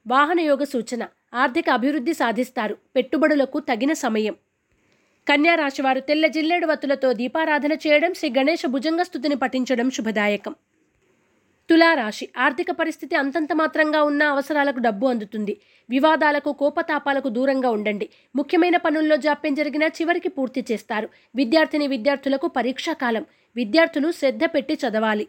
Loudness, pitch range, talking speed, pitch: -21 LUFS, 255-315 Hz, 110 wpm, 285 Hz